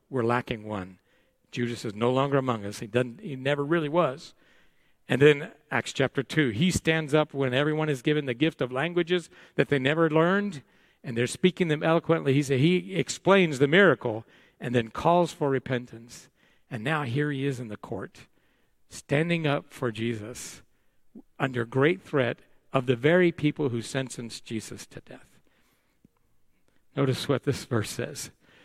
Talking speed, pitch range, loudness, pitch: 170 wpm, 125-160 Hz, -26 LUFS, 140 Hz